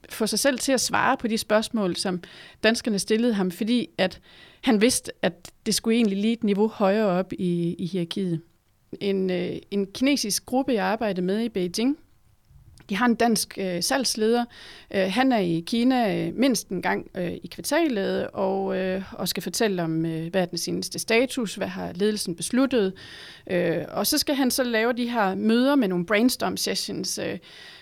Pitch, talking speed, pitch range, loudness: 210 Hz, 185 wpm, 185-235 Hz, -24 LUFS